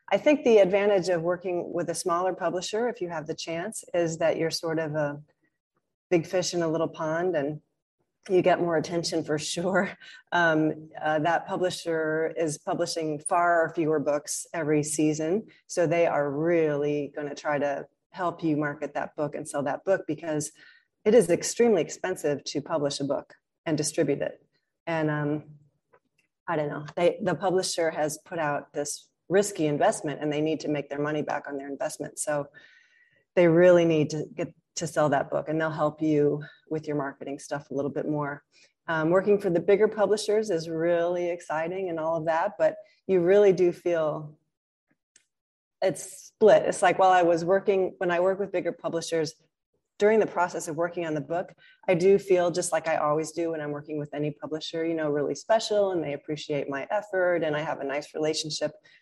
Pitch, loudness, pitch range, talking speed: 165 Hz, -26 LUFS, 150-180 Hz, 195 wpm